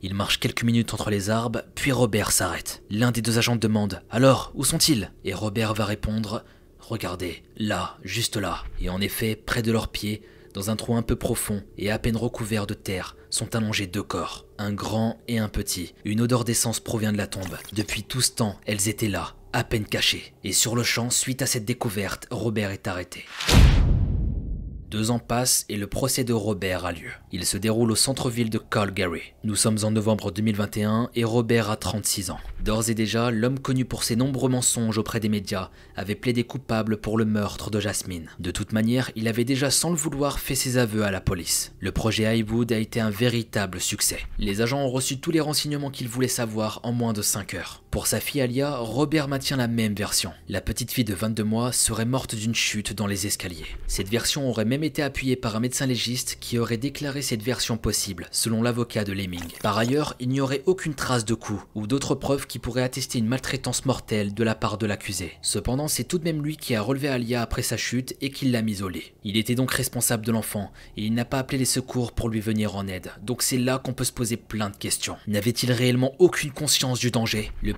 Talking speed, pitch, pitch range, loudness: 220 wpm, 115 Hz, 105-125 Hz, -25 LUFS